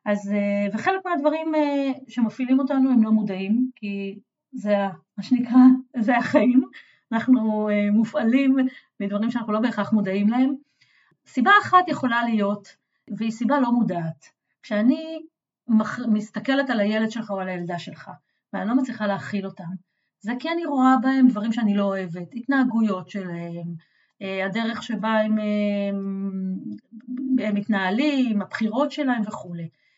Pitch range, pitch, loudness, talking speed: 200-255 Hz, 220 Hz, -22 LUFS, 130 wpm